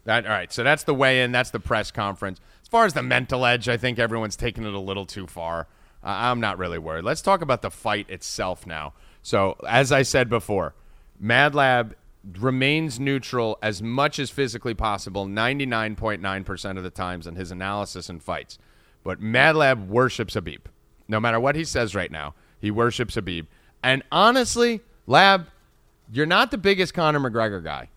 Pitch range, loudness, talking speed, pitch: 95-135 Hz, -23 LUFS, 185 wpm, 115 Hz